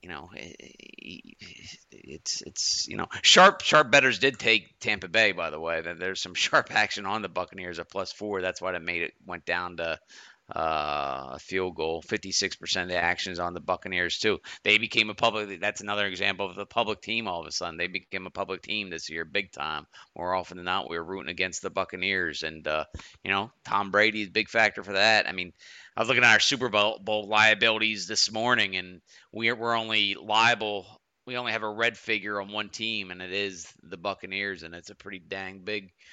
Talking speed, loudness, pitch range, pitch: 215 wpm, -26 LUFS, 90-110 Hz, 100 Hz